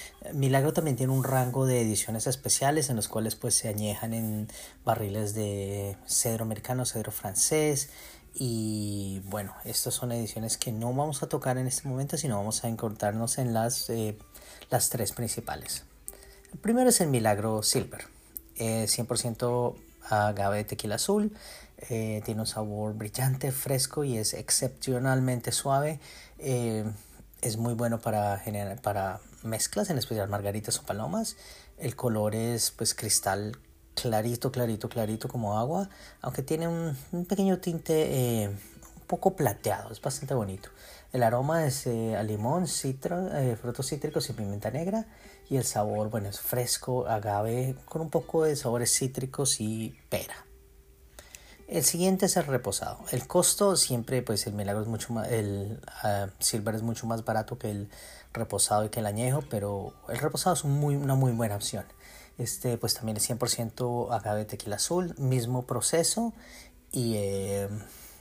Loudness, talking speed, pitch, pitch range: -29 LUFS, 160 wpm, 120 Hz, 105-135 Hz